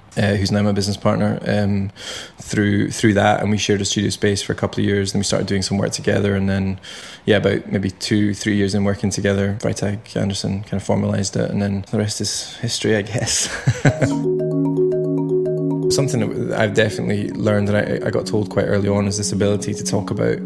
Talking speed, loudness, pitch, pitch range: 210 wpm, -19 LUFS, 100 Hz, 100-105 Hz